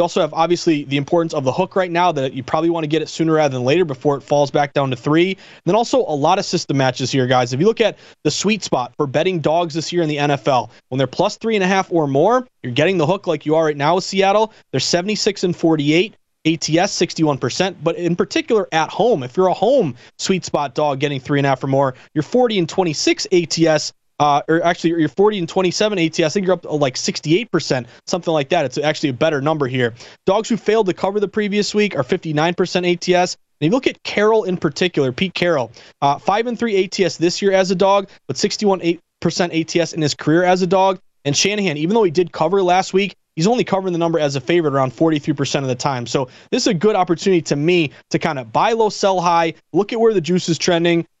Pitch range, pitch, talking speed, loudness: 150-190 Hz, 170 Hz, 245 wpm, -18 LUFS